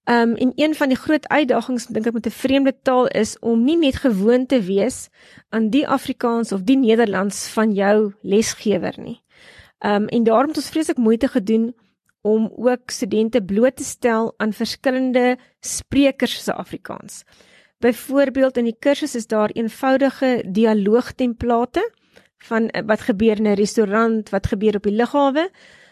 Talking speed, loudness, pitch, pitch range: 160 wpm, -19 LUFS, 235 Hz, 220-265 Hz